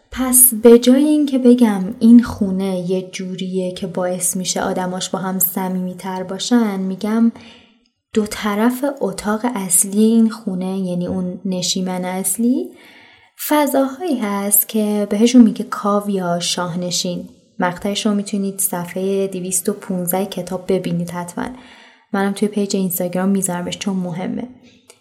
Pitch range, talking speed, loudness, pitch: 185-235 Hz, 125 wpm, -17 LUFS, 200 Hz